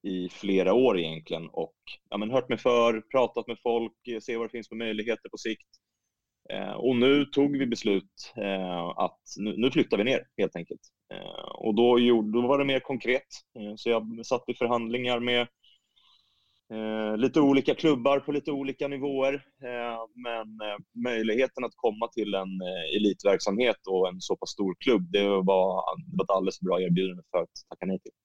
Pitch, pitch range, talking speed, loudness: 115 Hz, 100-125 Hz, 170 wpm, -28 LUFS